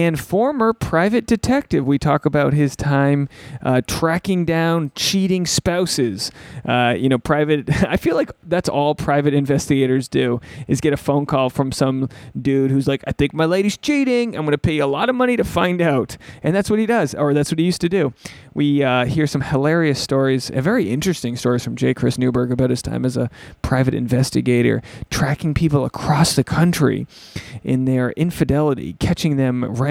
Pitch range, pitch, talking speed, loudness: 130-170 Hz, 145 Hz, 195 wpm, -18 LUFS